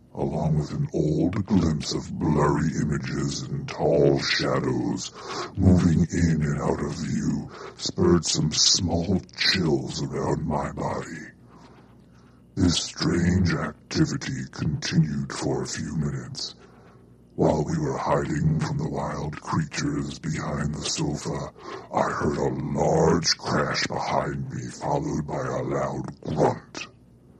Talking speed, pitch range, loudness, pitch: 120 wpm, 70-80 Hz, -25 LUFS, 75 Hz